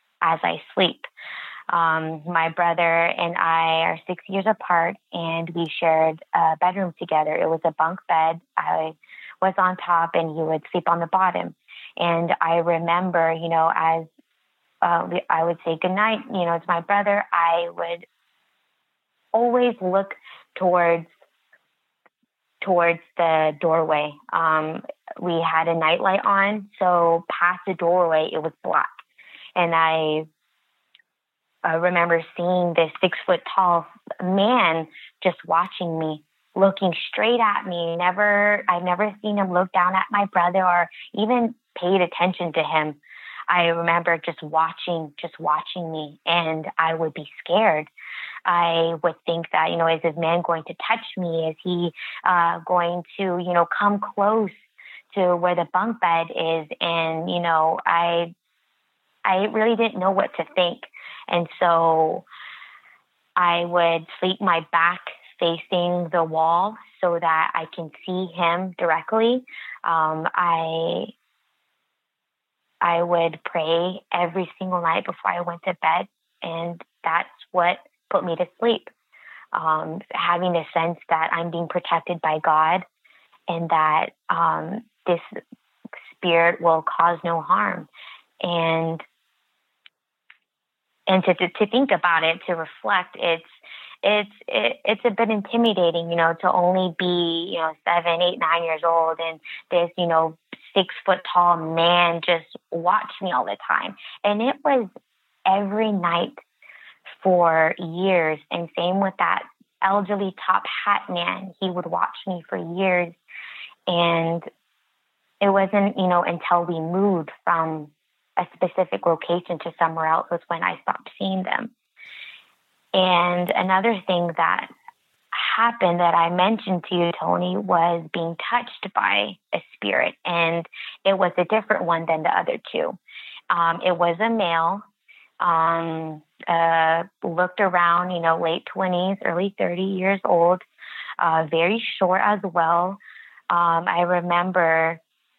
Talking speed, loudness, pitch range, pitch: 145 wpm, -22 LUFS, 165-185 Hz, 175 Hz